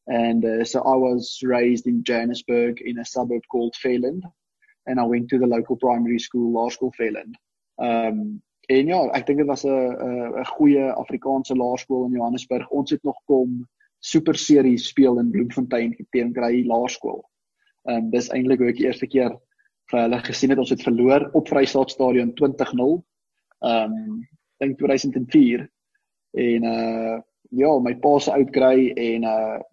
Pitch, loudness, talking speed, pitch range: 125 Hz, -21 LUFS, 170 wpm, 120-135 Hz